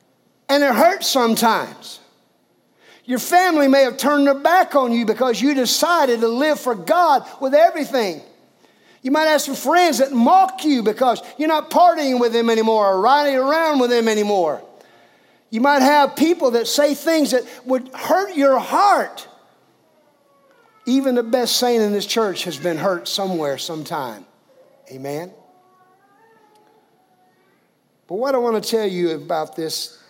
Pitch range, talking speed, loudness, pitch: 230-305 Hz, 155 wpm, -17 LUFS, 265 Hz